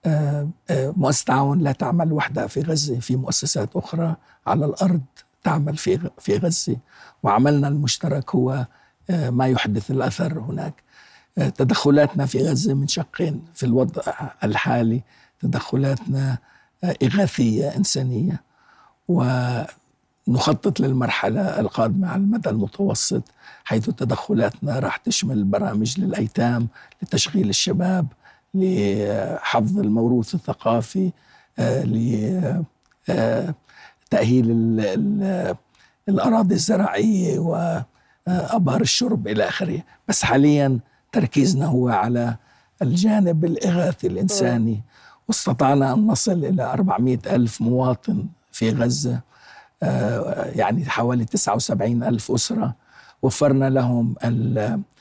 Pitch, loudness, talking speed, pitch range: 140 Hz, -21 LUFS, 90 wpm, 125-180 Hz